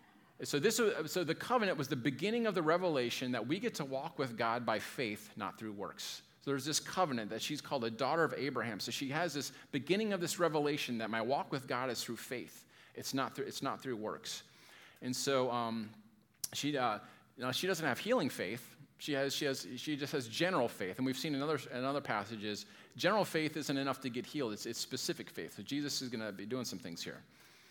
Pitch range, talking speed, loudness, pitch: 115-155 Hz, 235 wpm, -37 LUFS, 135 Hz